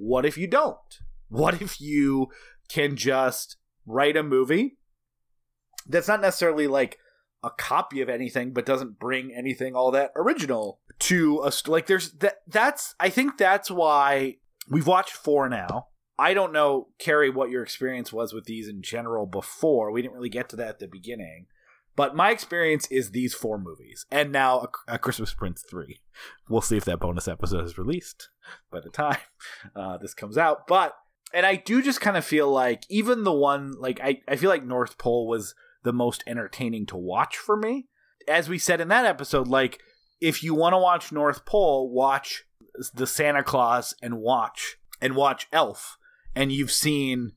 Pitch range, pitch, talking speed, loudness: 125-165 Hz, 135 Hz, 185 wpm, -25 LUFS